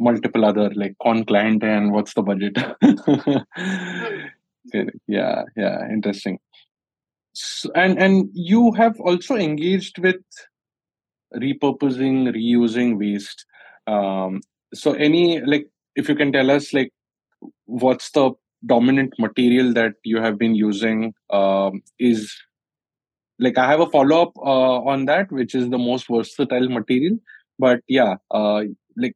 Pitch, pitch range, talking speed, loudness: 125 Hz, 110-145 Hz, 130 wpm, -19 LUFS